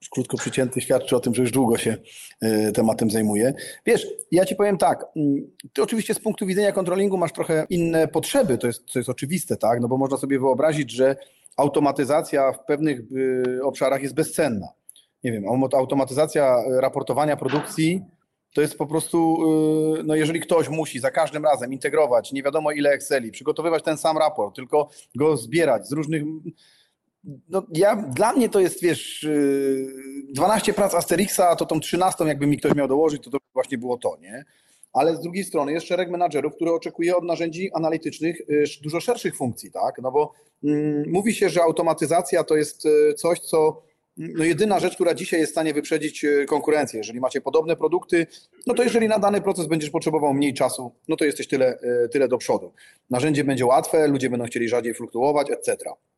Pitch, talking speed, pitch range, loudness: 155 Hz, 175 wpm, 135-170 Hz, -22 LUFS